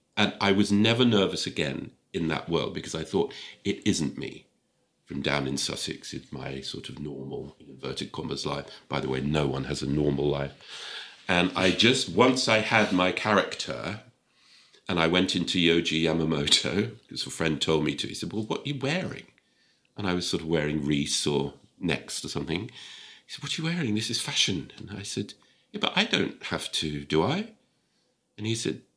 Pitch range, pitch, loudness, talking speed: 75-110 Hz, 90 Hz, -27 LUFS, 200 wpm